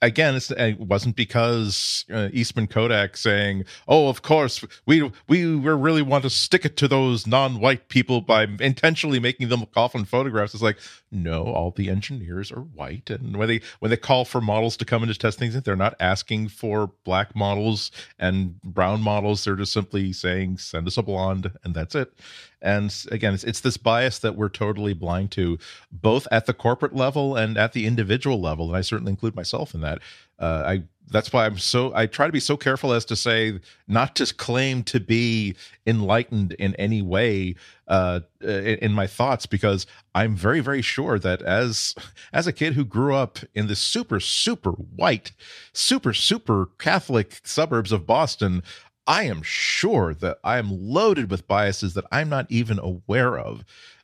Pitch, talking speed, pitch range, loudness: 110 Hz, 185 wpm, 100-125 Hz, -23 LUFS